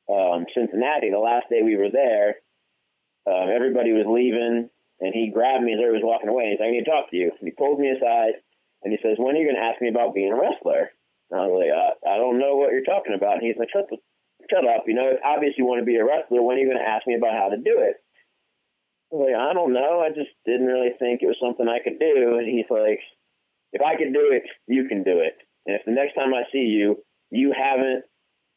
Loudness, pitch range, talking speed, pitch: -22 LUFS, 115-145 Hz, 270 wpm, 125 Hz